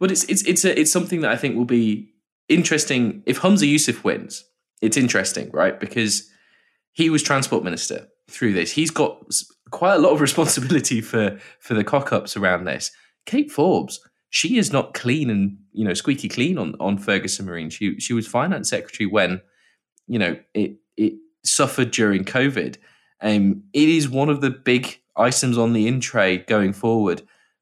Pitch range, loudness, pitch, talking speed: 105-155 Hz, -20 LUFS, 125 Hz, 180 wpm